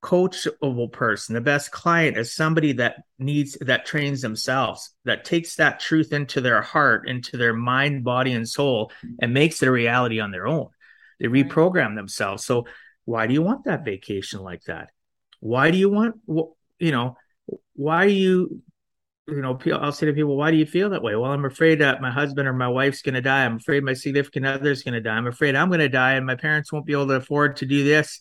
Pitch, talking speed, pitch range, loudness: 140 Hz, 215 wpm, 125-155 Hz, -22 LUFS